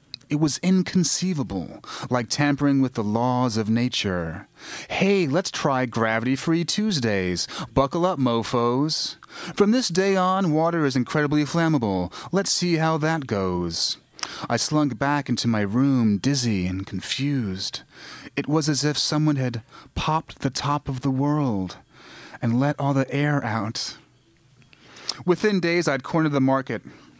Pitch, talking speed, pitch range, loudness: 140 Hz, 145 wpm, 115-160 Hz, -23 LUFS